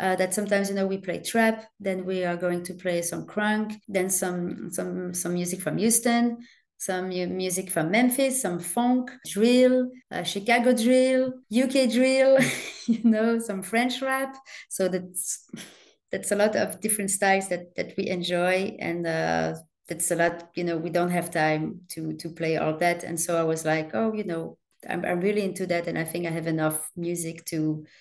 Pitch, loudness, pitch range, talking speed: 185 Hz, -25 LUFS, 170-225 Hz, 190 wpm